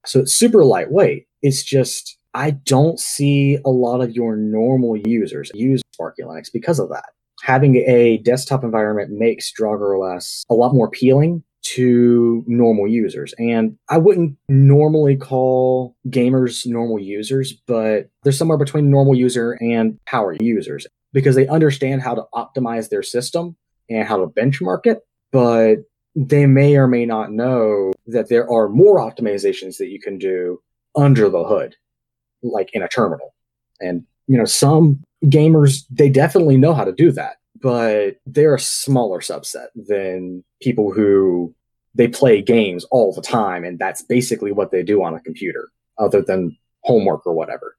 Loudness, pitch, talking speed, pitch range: -16 LUFS, 125 Hz, 160 wpm, 115-140 Hz